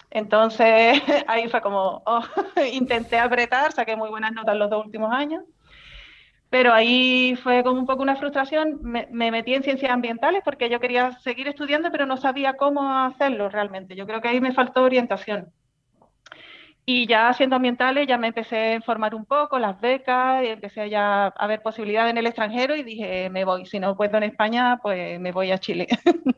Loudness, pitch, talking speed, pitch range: -21 LUFS, 240 Hz, 190 wpm, 215-260 Hz